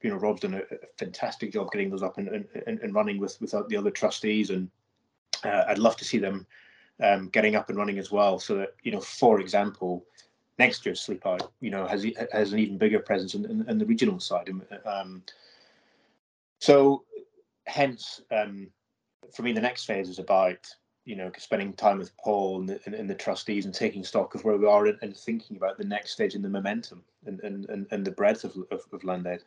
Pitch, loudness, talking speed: 110 Hz, -28 LUFS, 215 wpm